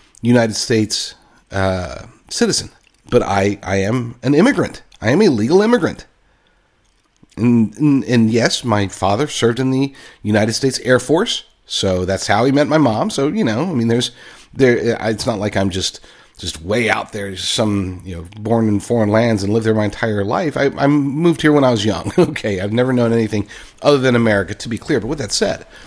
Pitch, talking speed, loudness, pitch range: 115 Hz, 200 wpm, -16 LUFS, 100-130 Hz